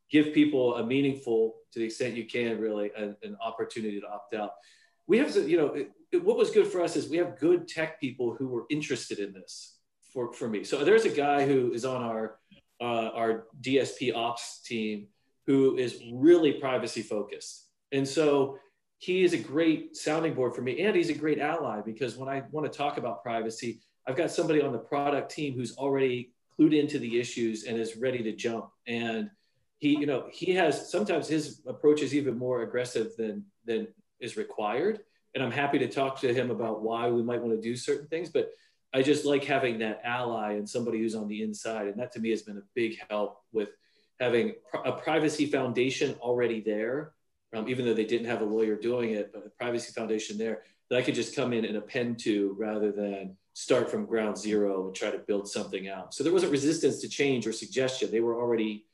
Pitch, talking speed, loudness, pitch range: 125 Hz, 215 wpm, -29 LUFS, 110-145 Hz